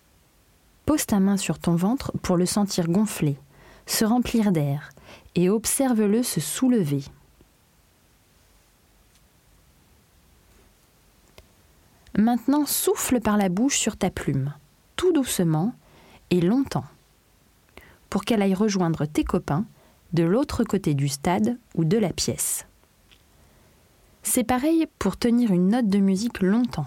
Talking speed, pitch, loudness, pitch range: 120 wpm, 190 Hz, -23 LUFS, 145-235 Hz